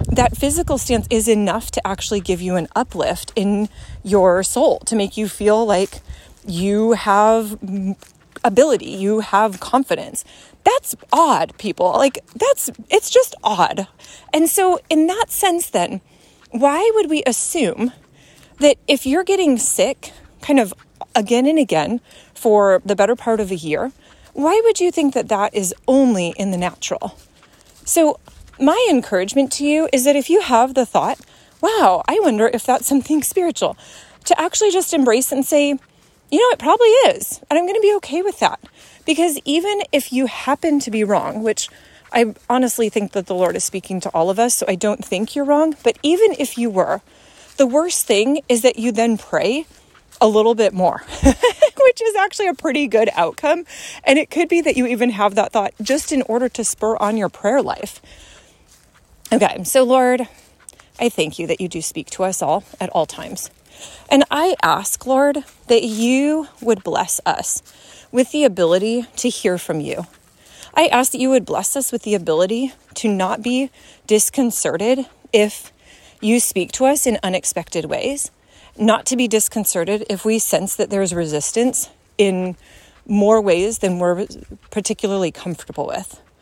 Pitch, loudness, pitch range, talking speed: 240 Hz, -17 LUFS, 205-290 Hz, 175 wpm